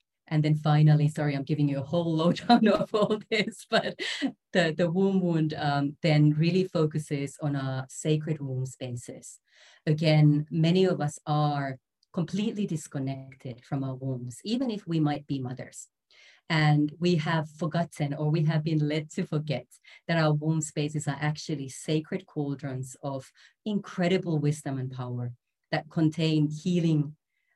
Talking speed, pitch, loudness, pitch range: 150 wpm, 155 Hz, -28 LUFS, 140-170 Hz